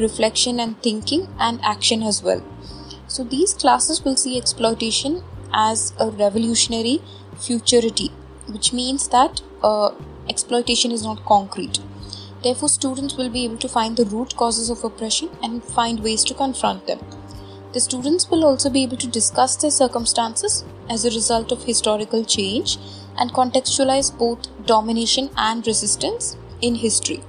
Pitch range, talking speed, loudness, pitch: 220-260 Hz, 145 wpm, -19 LUFS, 235 Hz